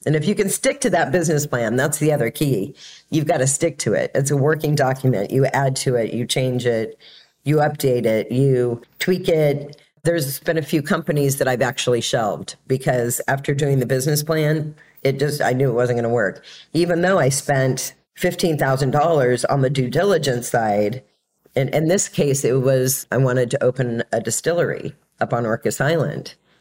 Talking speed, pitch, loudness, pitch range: 195 wpm, 140 Hz, -20 LUFS, 130-155 Hz